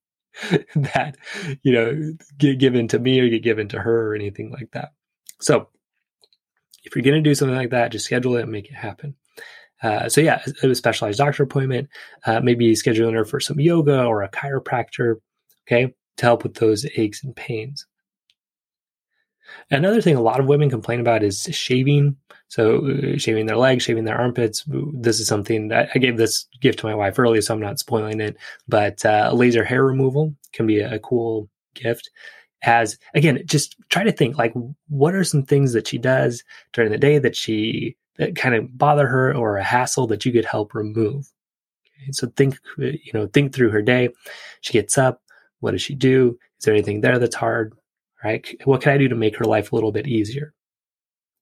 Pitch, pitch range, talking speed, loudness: 125 Hz, 115-140 Hz, 195 wpm, -20 LUFS